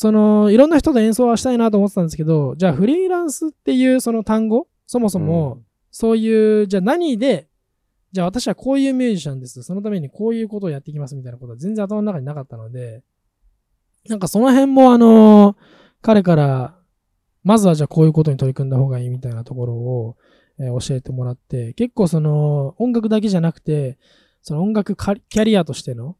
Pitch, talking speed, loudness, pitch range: 185 Hz, 425 characters per minute, -16 LUFS, 135-220 Hz